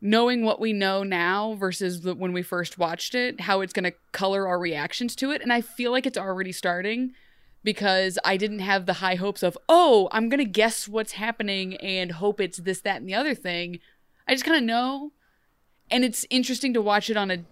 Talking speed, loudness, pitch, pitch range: 225 wpm, -25 LUFS, 205 Hz, 185-240 Hz